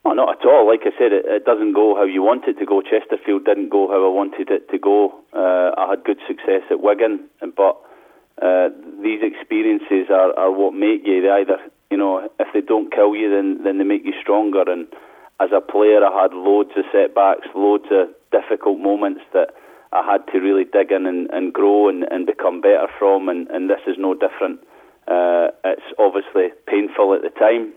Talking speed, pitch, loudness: 210 wpm, 310 Hz, -17 LUFS